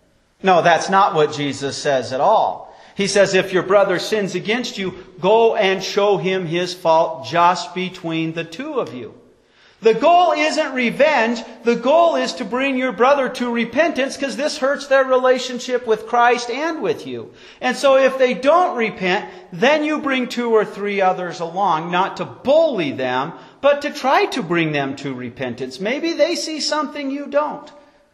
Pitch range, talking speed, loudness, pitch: 180-285 Hz, 175 wpm, -18 LUFS, 235 Hz